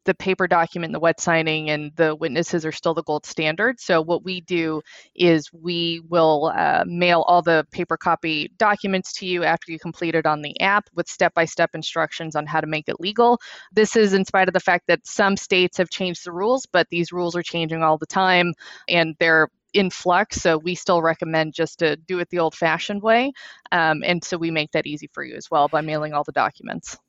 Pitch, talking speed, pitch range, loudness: 170 Hz, 225 wpm, 160-185 Hz, -21 LUFS